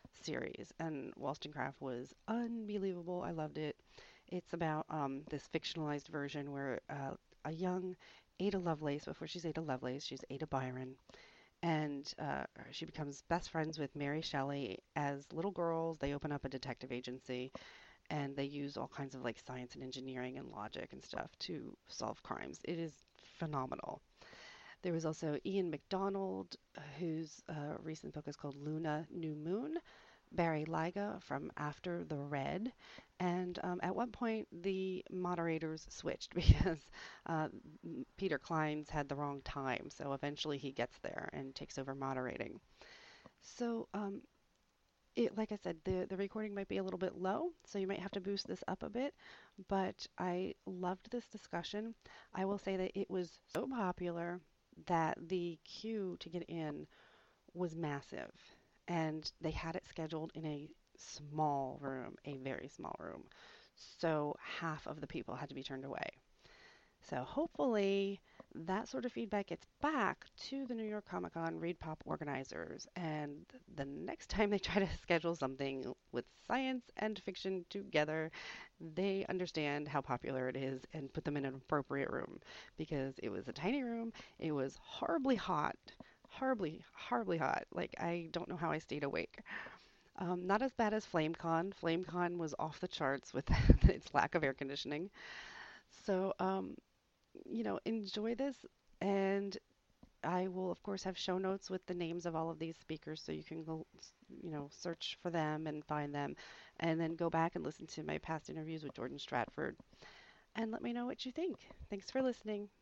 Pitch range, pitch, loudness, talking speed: 145-190 Hz, 165 Hz, -41 LUFS, 170 wpm